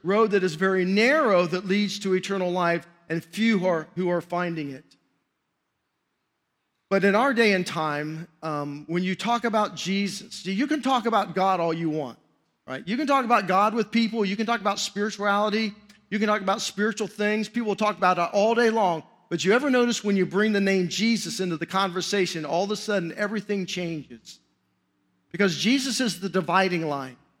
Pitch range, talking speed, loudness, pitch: 170-215 Hz, 195 wpm, -24 LUFS, 195 Hz